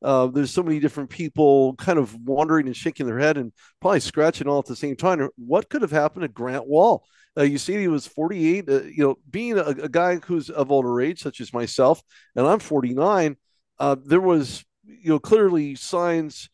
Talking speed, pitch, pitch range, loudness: 210 wpm, 150 Hz, 135-170 Hz, -22 LUFS